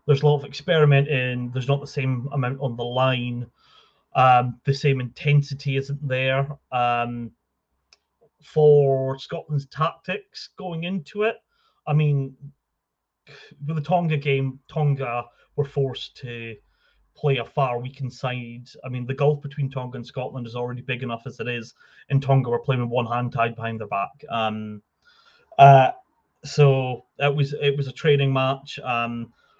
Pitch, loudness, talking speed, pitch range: 135 Hz, -23 LUFS, 160 wpm, 125-145 Hz